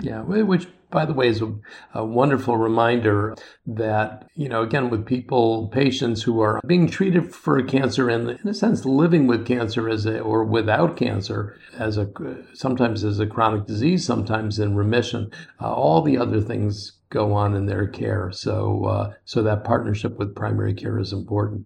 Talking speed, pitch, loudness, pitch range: 175 wpm, 115 Hz, -22 LUFS, 105-125 Hz